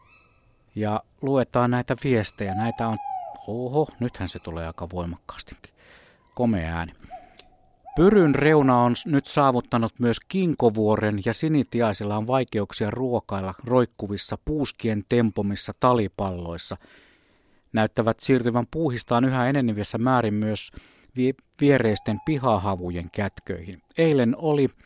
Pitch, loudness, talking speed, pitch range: 115 Hz, -24 LUFS, 105 wpm, 105-130 Hz